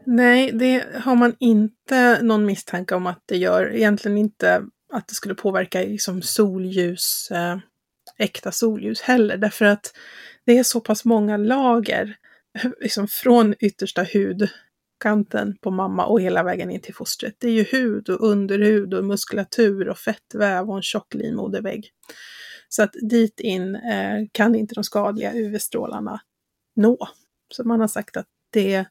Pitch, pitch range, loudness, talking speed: 215 Hz, 195-230 Hz, -20 LUFS, 150 wpm